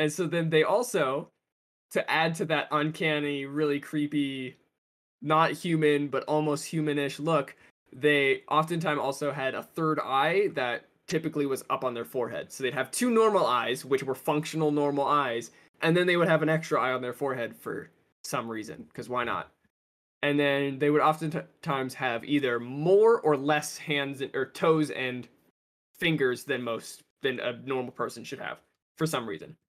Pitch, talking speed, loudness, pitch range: 145 Hz, 175 wpm, -28 LUFS, 135-155 Hz